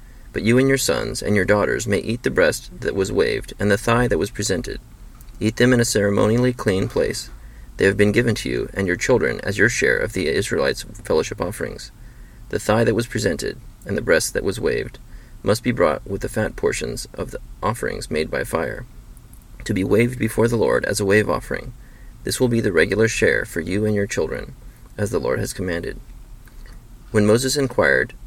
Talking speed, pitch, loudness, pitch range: 210 wpm, 110 Hz, -20 LUFS, 105-120 Hz